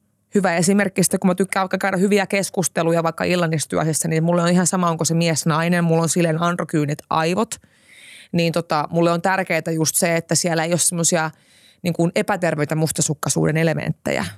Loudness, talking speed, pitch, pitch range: -19 LUFS, 175 wpm, 170 Hz, 160-185 Hz